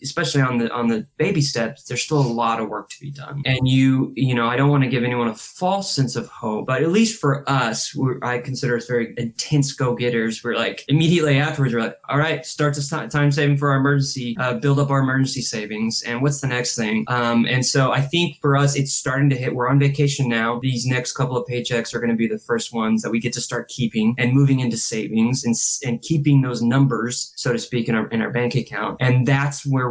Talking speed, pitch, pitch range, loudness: 250 wpm, 130 Hz, 120-140 Hz, -18 LUFS